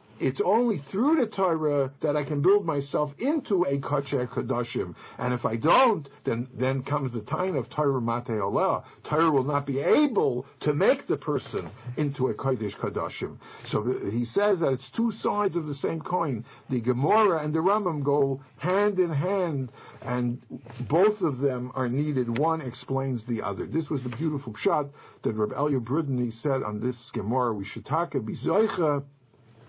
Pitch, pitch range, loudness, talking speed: 140 Hz, 125-160 Hz, -27 LUFS, 175 wpm